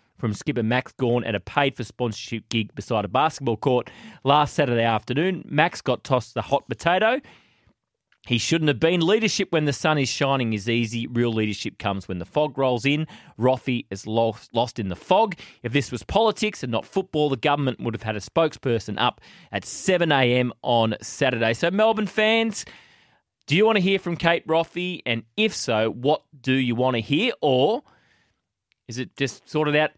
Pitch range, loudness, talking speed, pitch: 115-155 Hz, -23 LUFS, 190 wpm, 130 Hz